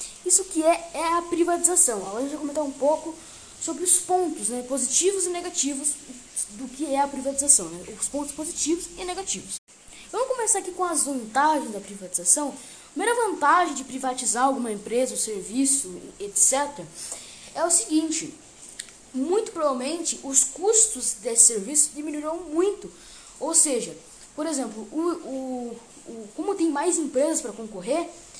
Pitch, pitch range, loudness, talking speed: 290 Hz, 255-340 Hz, -23 LUFS, 150 wpm